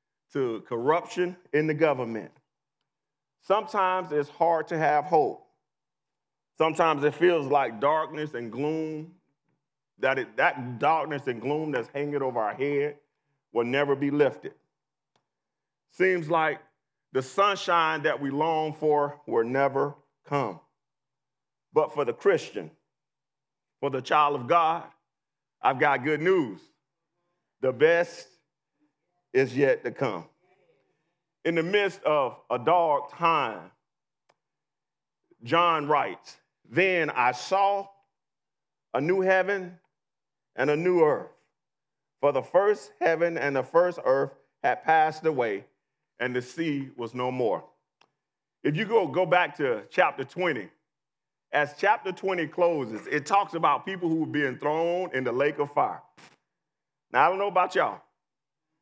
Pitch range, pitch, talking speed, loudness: 145-175 Hz, 155 Hz, 135 wpm, -26 LUFS